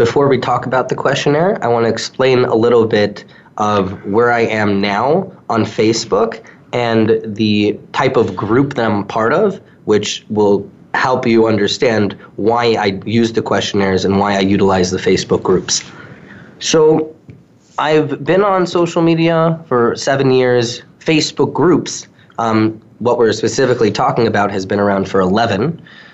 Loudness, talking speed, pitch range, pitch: -14 LUFS, 155 wpm, 105-140 Hz, 115 Hz